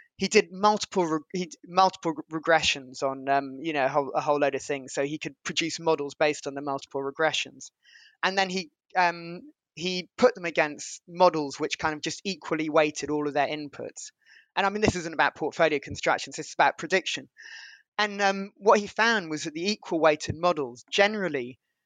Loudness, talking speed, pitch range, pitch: -26 LUFS, 190 wpm, 145-185 Hz, 160 Hz